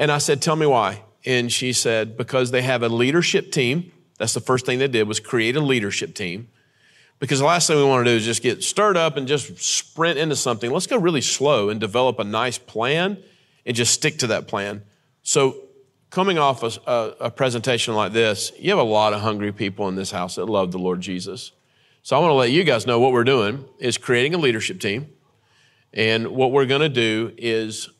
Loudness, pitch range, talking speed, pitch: -20 LUFS, 110-145 Hz, 225 wpm, 125 Hz